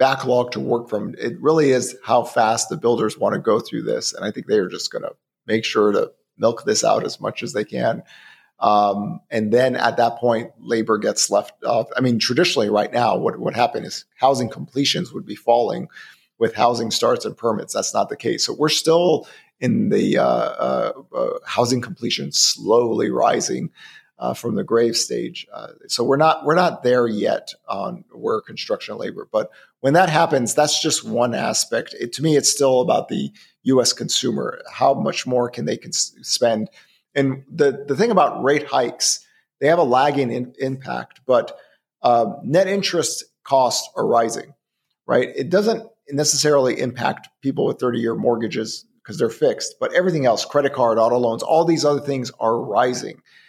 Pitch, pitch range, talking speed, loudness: 135 Hz, 120-160 Hz, 185 wpm, -20 LUFS